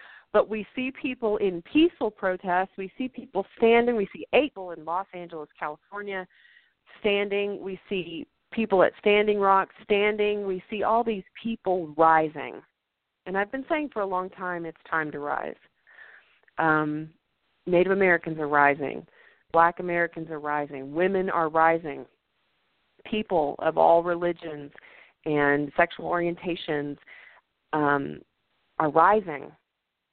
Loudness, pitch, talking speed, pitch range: -25 LUFS, 180 Hz, 130 wpm, 160-205 Hz